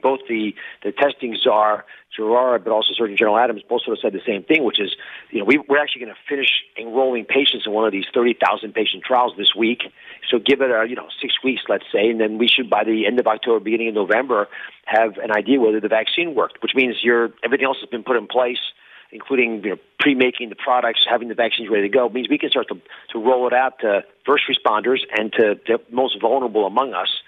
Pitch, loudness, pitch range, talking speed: 120 Hz, -19 LUFS, 110-130 Hz, 240 wpm